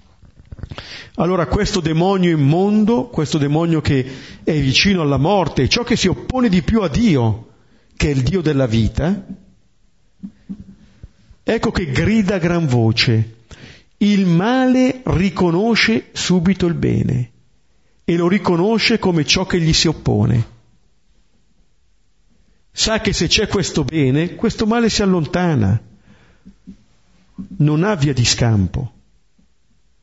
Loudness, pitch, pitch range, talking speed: -16 LUFS, 170 Hz, 130-200 Hz, 120 wpm